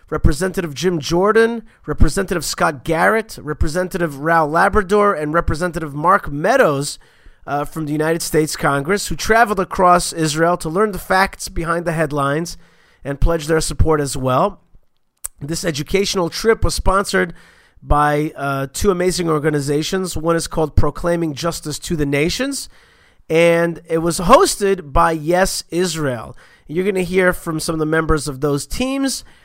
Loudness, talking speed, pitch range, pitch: -17 LUFS, 150 wpm, 155-185 Hz, 170 Hz